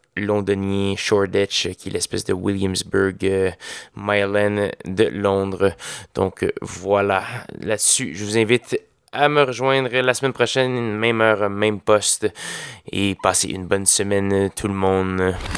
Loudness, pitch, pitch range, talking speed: -20 LUFS, 100 Hz, 95-110 Hz, 135 wpm